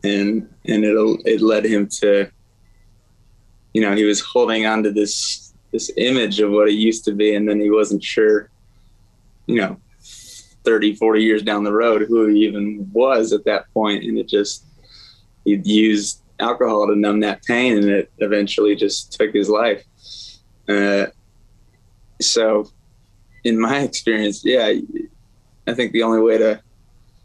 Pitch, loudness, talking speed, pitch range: 105 Hz, -18 LUFS, 160 wpm, 105-110 Hz